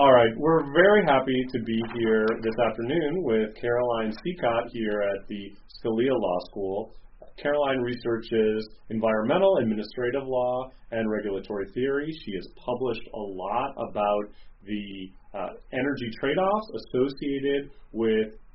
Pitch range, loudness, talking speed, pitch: 110-130 Hz, -26 LUFS, 130 wpm, 115 Hz